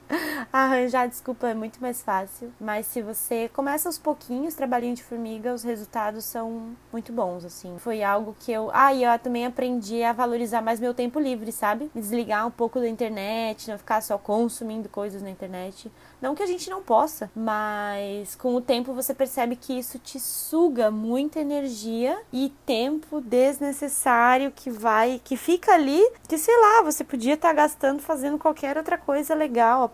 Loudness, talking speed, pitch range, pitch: -25 LUFS, 175 wpm, 225-280 Hz, 245 Hz